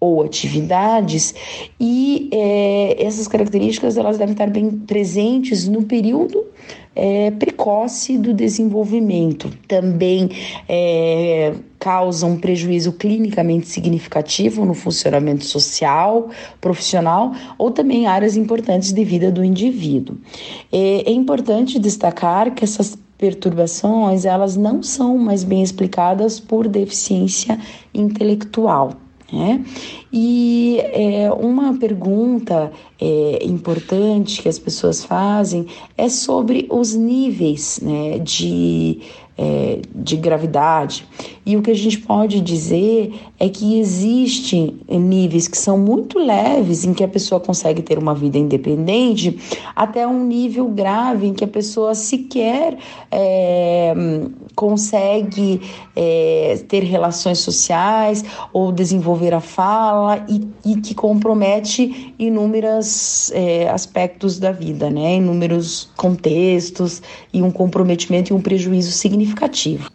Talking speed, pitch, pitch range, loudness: 115 wpm, 200 Hz, 175-225 Hz, -17 LUFS